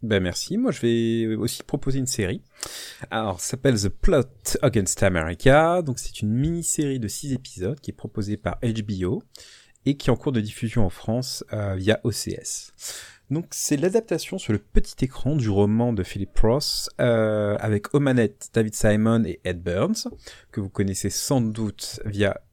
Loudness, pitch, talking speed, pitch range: -24 LUFS, 115 Hz, 175 wpm, 105-135 Hz